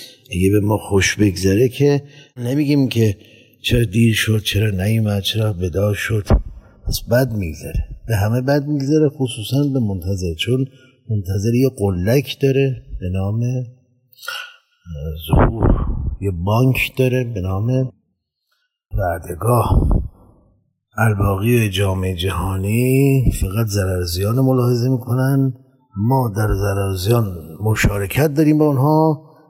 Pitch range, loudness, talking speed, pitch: 100-130 Hz, -18 LUFS, 110 wpm, 115 Hz